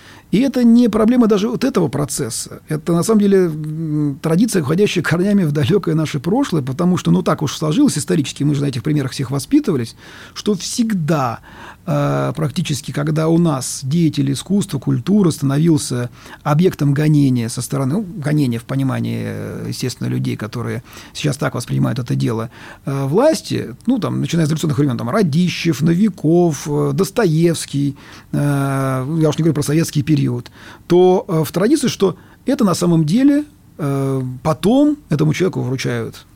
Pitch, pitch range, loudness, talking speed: 155 Hz, 135-180 Hz, -17 LUFS, 145 wpm